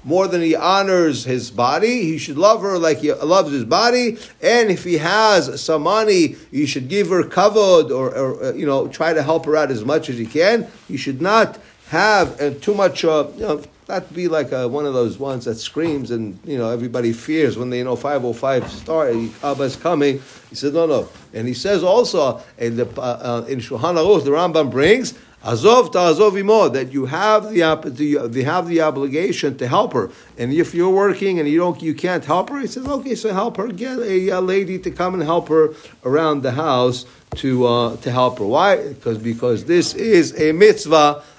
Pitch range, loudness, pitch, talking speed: 135-190 Hz, -18 LUFS, 155 Hz, 215 wpm